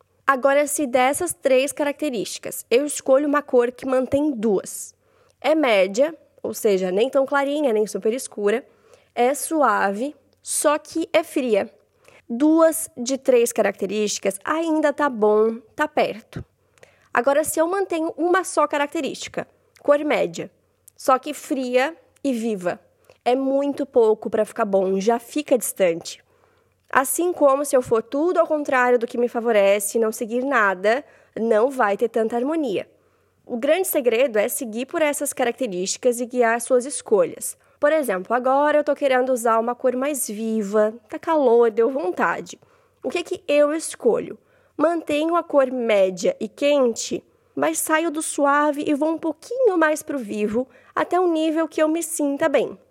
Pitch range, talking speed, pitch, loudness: 235-310 Hz, 160 wpm, 275 Hz, -21 LUFS